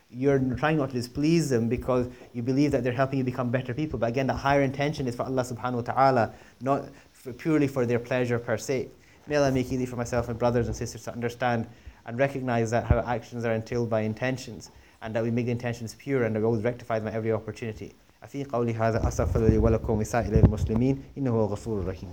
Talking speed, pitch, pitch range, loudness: 195 wpm, 120 Hz, 115-130 Hz, -27 LUFS